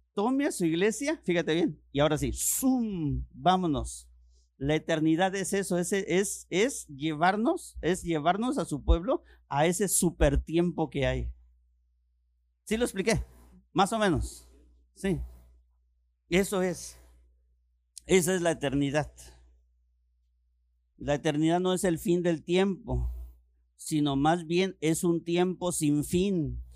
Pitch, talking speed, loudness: 155 Hz, 130 wpm, -28 LUFS